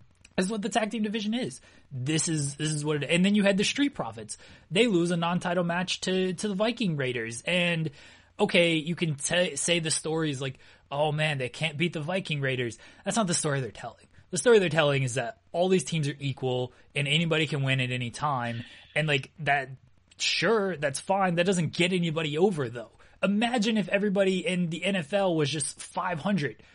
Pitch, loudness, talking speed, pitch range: 165 Hz, -27 LUFS, 210 wpm, 140-185 Hz